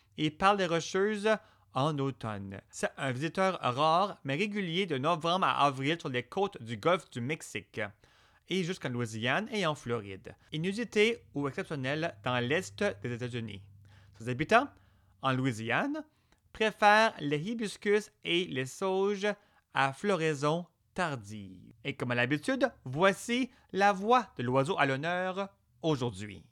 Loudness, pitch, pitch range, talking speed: -31 LUFS, 155 Hz, 125-195 Hz, 140 wpm